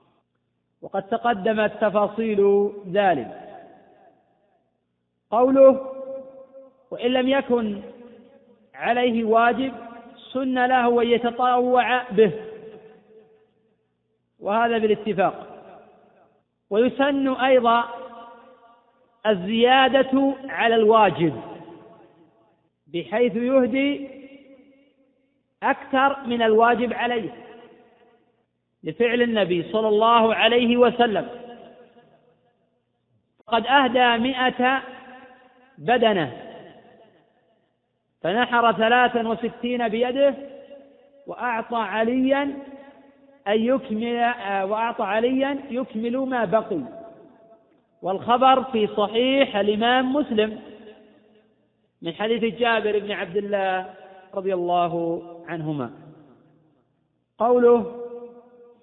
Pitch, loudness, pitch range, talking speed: 235 Hz, -21 LUFS, 220-255 Hz, 65 wpm